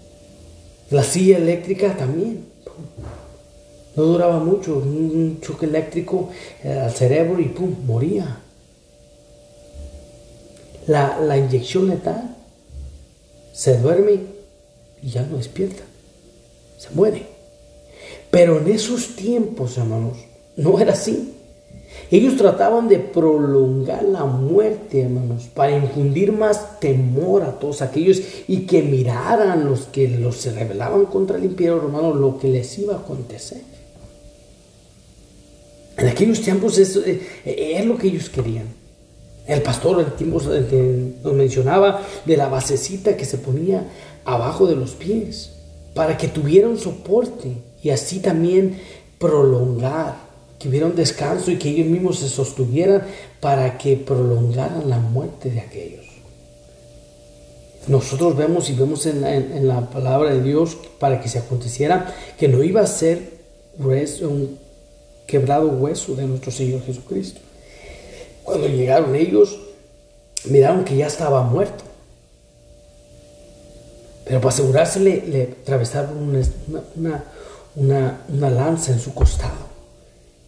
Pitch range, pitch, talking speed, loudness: 130-175 Hz, 140 Hz, 125 wpm, -19 LUFS